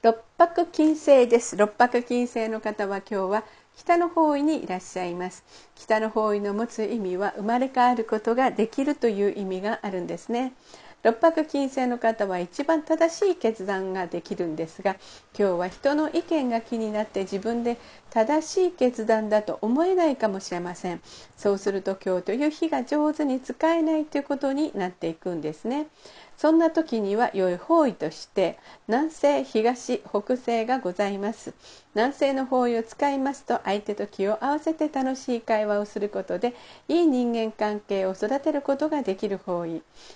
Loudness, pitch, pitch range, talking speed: -25 LUFS, 230 Hz, 205-285 Hz, 340 characters per minute